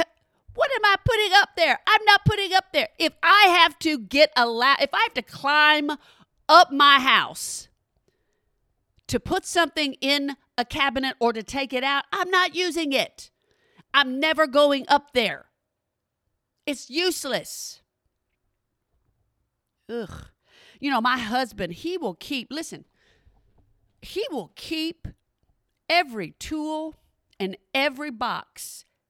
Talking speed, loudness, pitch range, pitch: 135 wpm, -21 LUFS, 270-345 Hz, 300 Hz